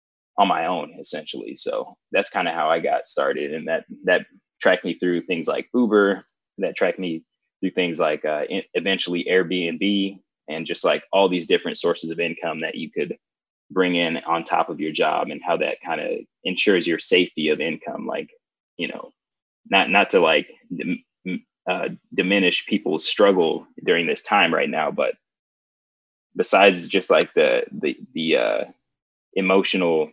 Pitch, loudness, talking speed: 95 Hz, -22 LUFS, 165 wpm